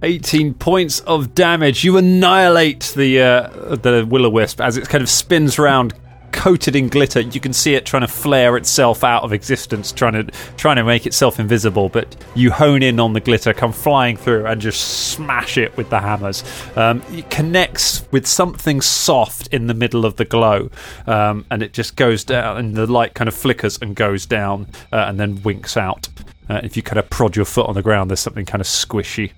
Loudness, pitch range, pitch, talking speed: -15 LUFS, 110-135 Hz, 120 Hz, 210 wpm